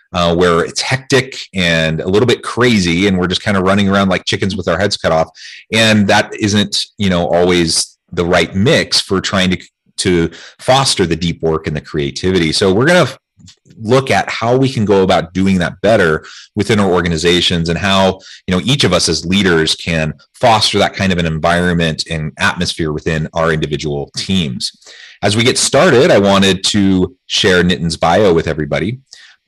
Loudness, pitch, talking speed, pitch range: -13 LUFS, 90 Hz, 195 wpm, 85-100 Hz